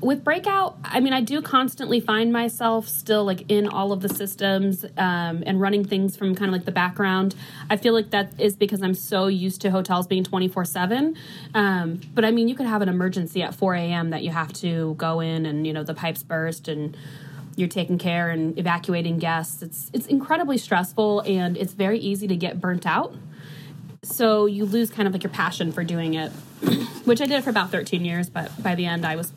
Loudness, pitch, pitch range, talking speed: -23 LUFS, 190 Hz, 170-210 Hz, 220 wpm